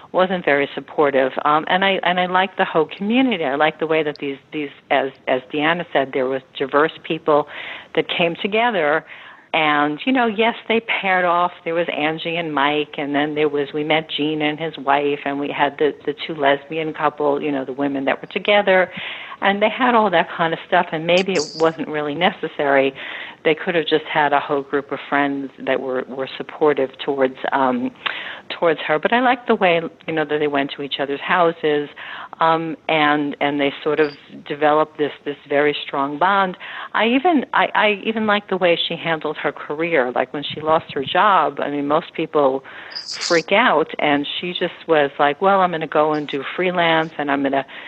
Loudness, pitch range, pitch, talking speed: -19 LUFS, 145-175 Hz, 155 Hz, 210 wpm